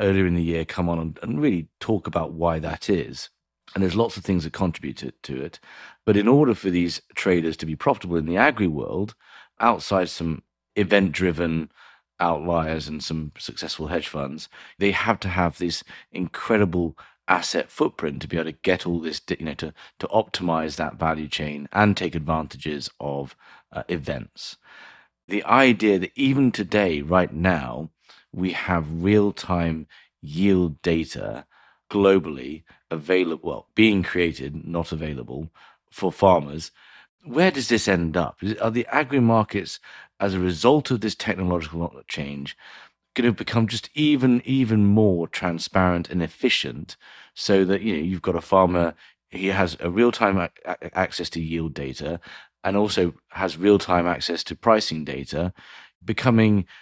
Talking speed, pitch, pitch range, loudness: 160 wpm, 90 Hz, 80-100 Hz, -23 LUFS